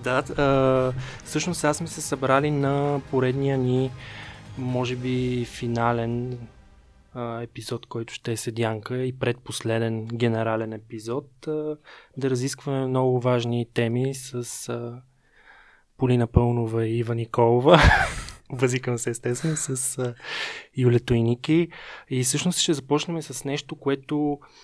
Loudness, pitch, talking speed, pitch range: -25 LUFS, 125 Hz, 125 wpm, 120-140 Hz